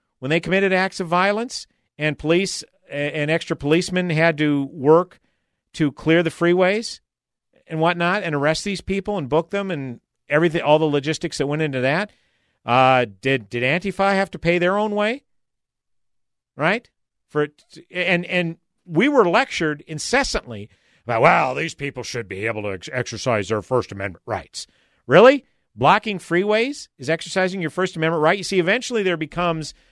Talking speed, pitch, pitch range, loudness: 165 wpm, 165 Hz, 145-185 Hz, -20 LUFS